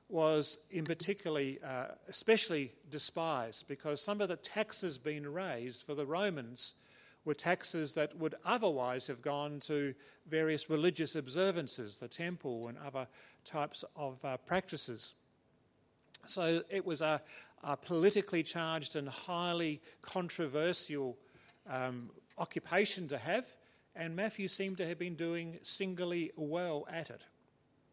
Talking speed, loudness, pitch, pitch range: 130 wpm, -37 LUFS, 155 Hz, 145-175 Hz